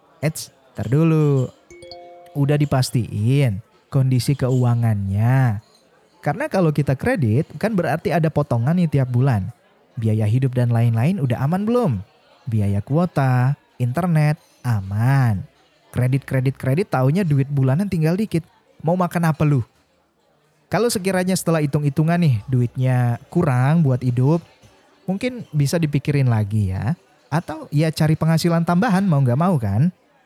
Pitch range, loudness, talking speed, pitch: 125-165 Hz, -20 LUFS, 120 wpm, 140 Hz